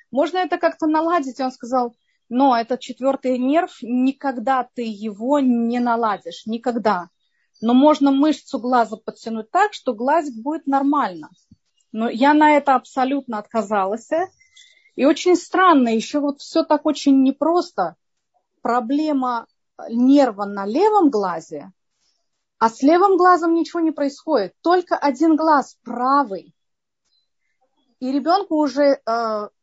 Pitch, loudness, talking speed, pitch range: 275 Hz, -19 LUFS, 125 wpm, 240-315 Hz